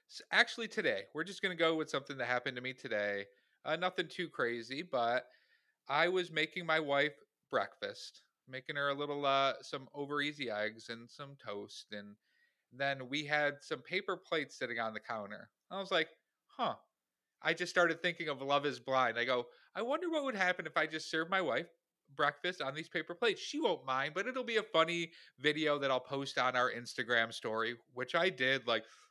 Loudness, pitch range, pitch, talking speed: -36 LUFS, 130-175 Hz, 145 Hz, 200 wpm